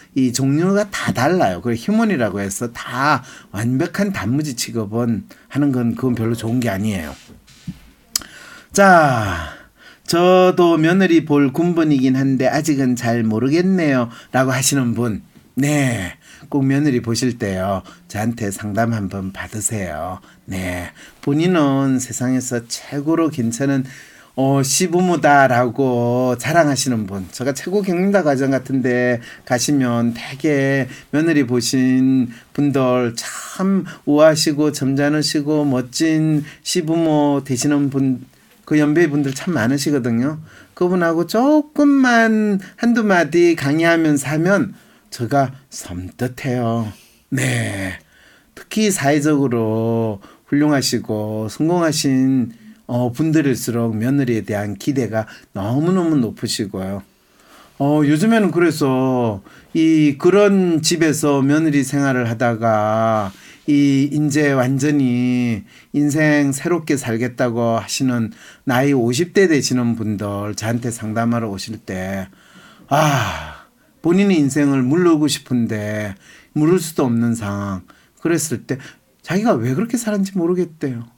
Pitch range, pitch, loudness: 115-155 Hz, 135 Hz, -18 LUFS